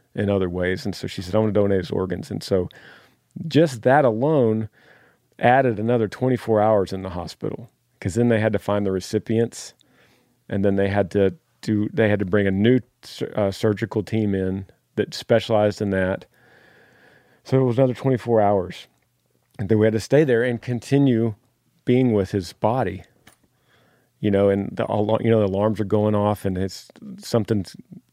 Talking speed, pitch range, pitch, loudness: 180 wpm, 100-120 Hz, 110 Hz, -21 LUFS